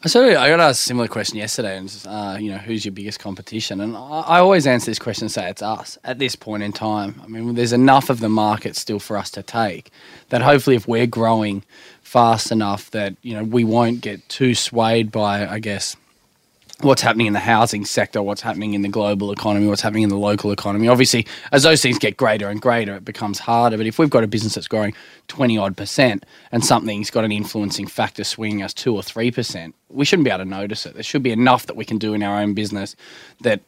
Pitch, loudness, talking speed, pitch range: 110 Hz, -18 LUFS, 240 wpm, 105-120 Hz